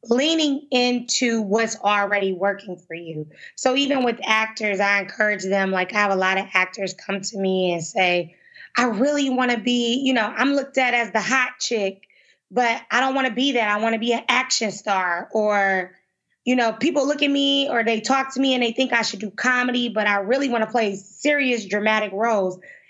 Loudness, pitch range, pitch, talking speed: -21 LUFS, 200-255 Hz, 225 Hz, 215 wpm